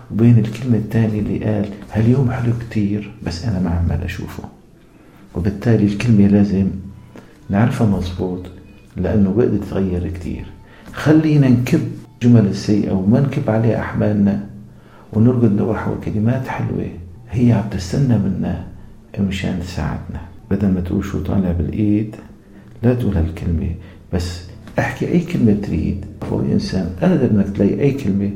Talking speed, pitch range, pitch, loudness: 130 wpm, 95-115 Hz, 105 Hz, -18 LUFS